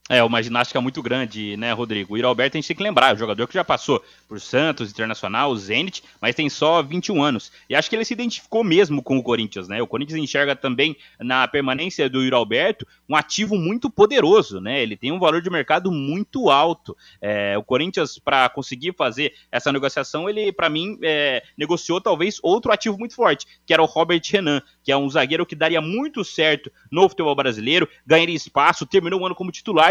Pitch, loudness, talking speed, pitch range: 155 Hz, -20 LUFS, 210 wpm, 130-185 Hz